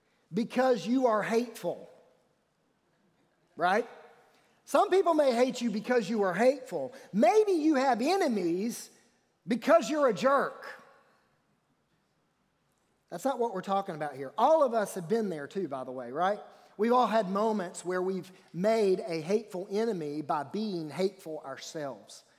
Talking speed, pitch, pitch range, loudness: 145 wpm, 220 Hz, 185-255 Hz, -29 LUFS